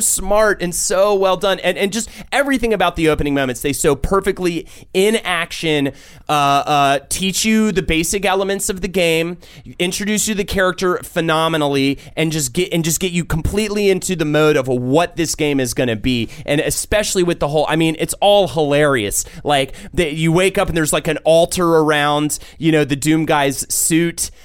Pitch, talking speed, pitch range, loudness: 165 Hz, 190 wpm, 145-190 Hz, -16 LUFS